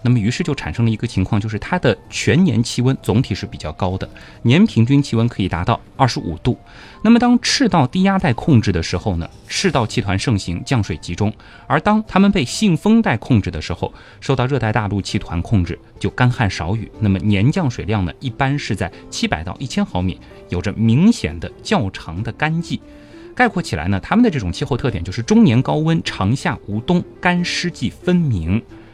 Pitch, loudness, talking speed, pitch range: 115 Hz, -18 LUFS, 310 characters per minute, 100-150 Hz